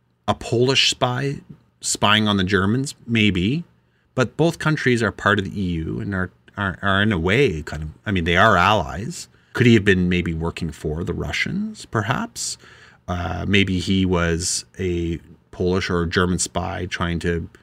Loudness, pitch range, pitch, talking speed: -20 LUFS, 85-115 Hz, 95 Hz, 175 wpm